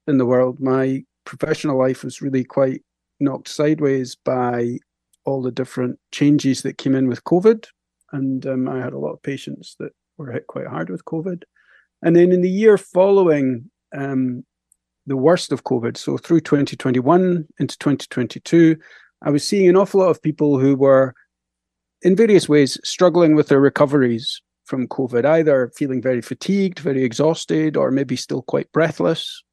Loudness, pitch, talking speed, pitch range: -18 LUFS, 140 Hz, 165 wpm, 130-160 Hz